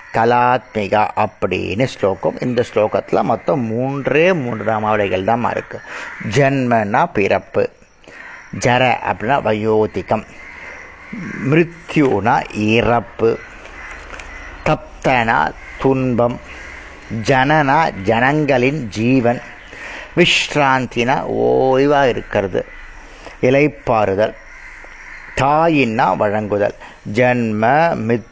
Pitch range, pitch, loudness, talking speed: 110-135 Hz, 120 Hz, -16 LUFS, 65 wpm